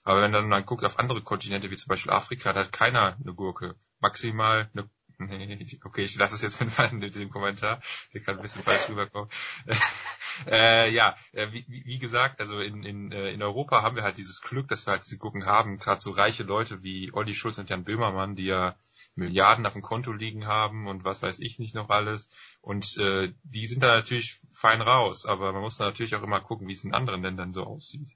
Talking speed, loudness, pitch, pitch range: 220 wpm, -26 LUFS, 105 Hz, 100-115 Hz